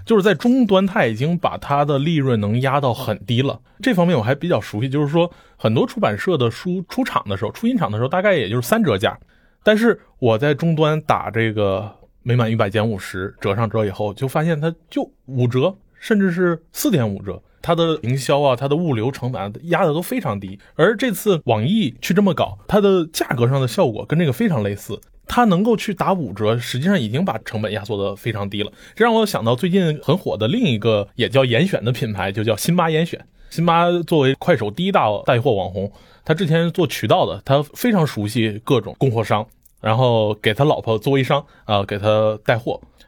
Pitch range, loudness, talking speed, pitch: 110-175 Hz, -19 LUFS, 315 characters per minute, 140 Hz